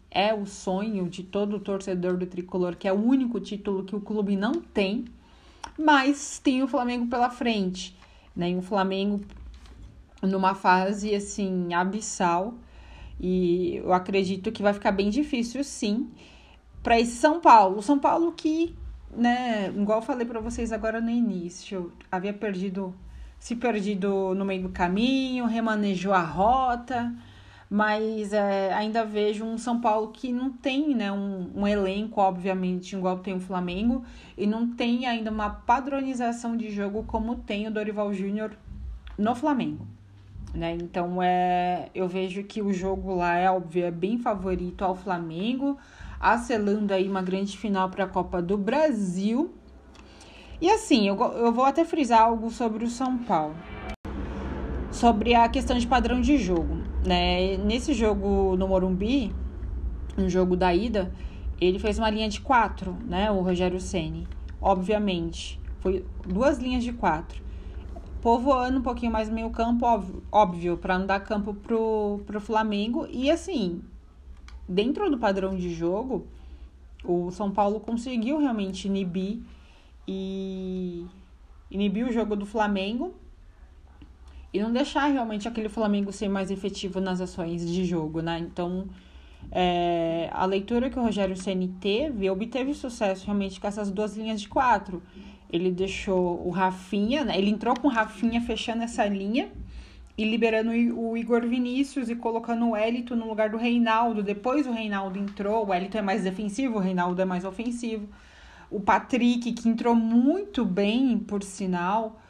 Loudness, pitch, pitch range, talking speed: -26 LUFS, 205 Hz, 185-235 Hz, 155 wpm